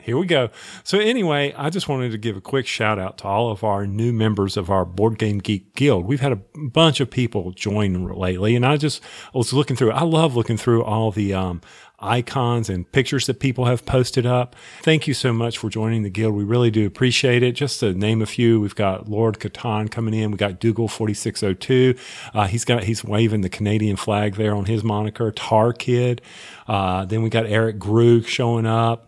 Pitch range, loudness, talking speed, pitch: 105-125 Hz, -20 LUFS, 225 wpm, 115 Hz